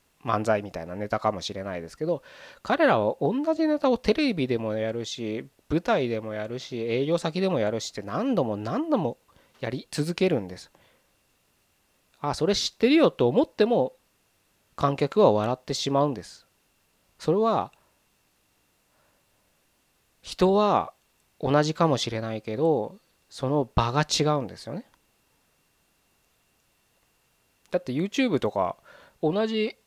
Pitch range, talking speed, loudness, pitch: 110-170 Hz, 265 characters per minute, -26 LUFS, 135 Hz